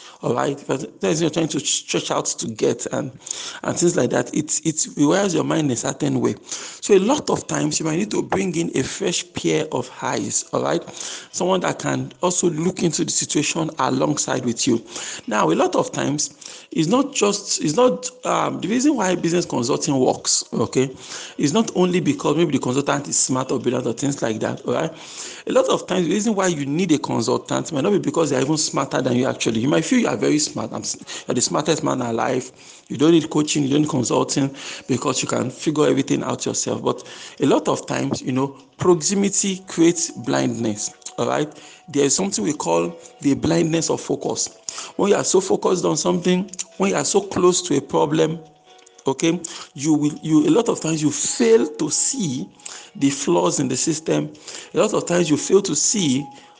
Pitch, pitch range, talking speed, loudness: 160 Hz, 140-185 Hz, 210 wpm, -20 LUFS